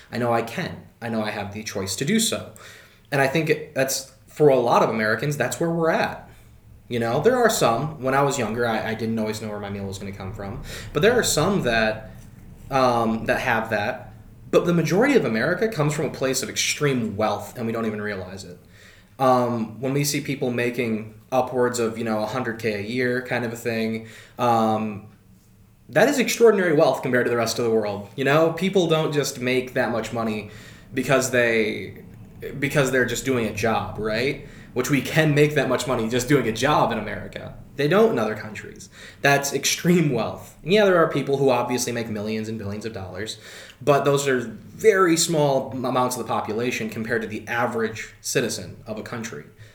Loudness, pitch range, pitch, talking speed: -22 LUFS, 110-140 Hz, 120 Hz, 210 wpm